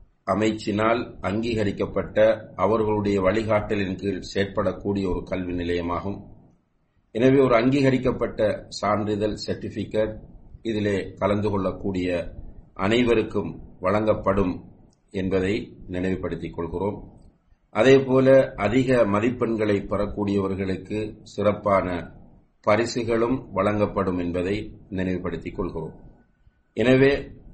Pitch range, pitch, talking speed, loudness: 95-110 Hz, 105 Hz, 70 wpm, -24 LUFS